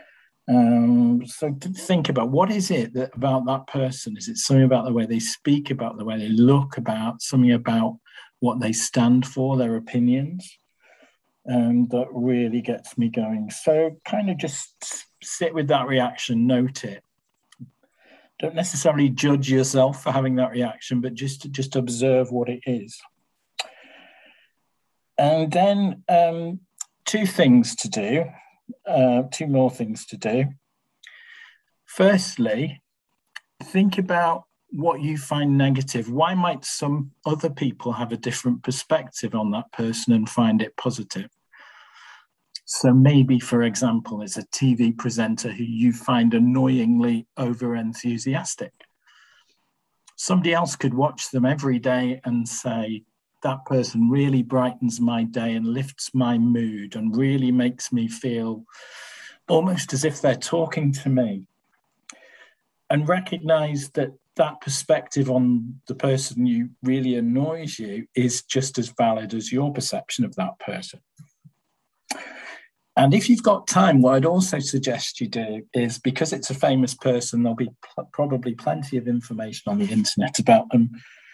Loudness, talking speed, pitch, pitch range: -22 LUFS, 145 wpm, 130 Hz, 120-155 Hz